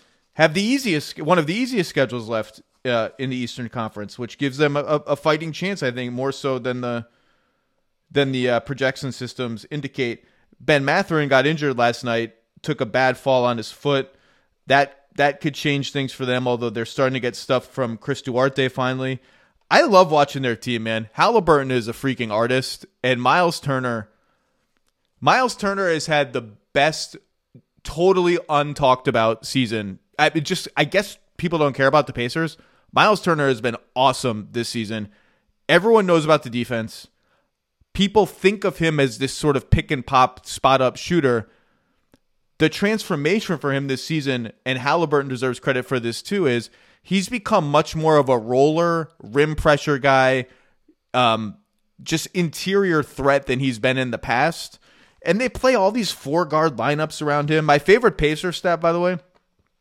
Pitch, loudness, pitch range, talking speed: 140 Hz, -20 LUFS, 125-160 Hz, 175 wpm